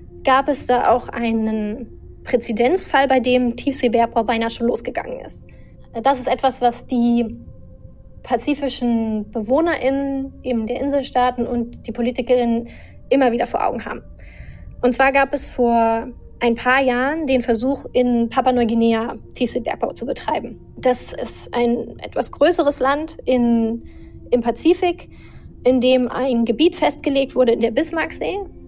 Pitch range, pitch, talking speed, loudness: 235-270 Hz, 250 Hz, 135 wpm, -19 LUFS